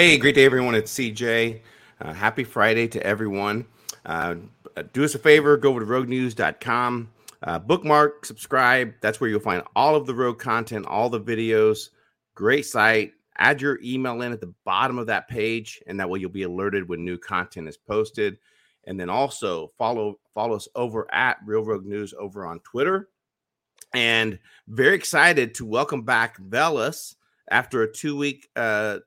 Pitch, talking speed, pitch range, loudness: 115 Hz, 175 wpm, 105-130 Hz, -22 LUFS